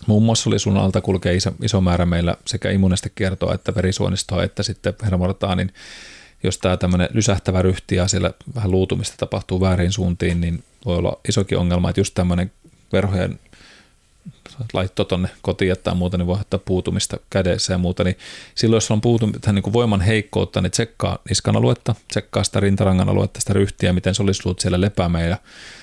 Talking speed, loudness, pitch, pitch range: 180 wpm, -20 LUFS, 95 Hz, 90-105 Hz